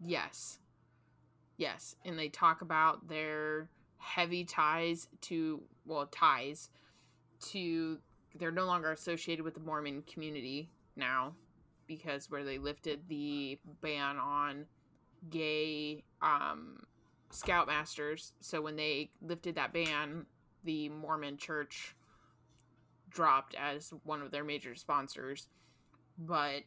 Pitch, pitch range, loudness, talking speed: 150 Hz, 145-160 Hz, -37 LUFS, 110 wpm